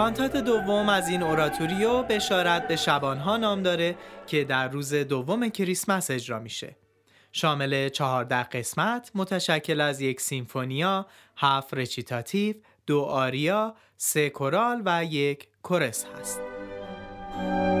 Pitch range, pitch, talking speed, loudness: 130-190 Hz, 150 Hz, 115 wpm, -26 LUFS